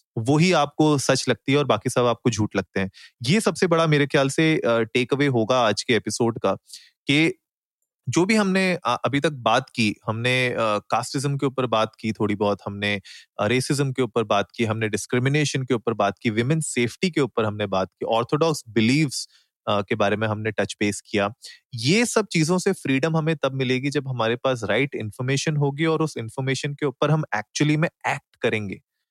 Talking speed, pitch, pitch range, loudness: 190 wpm, 130 Hz, 110-150 Hz, -22 LUFS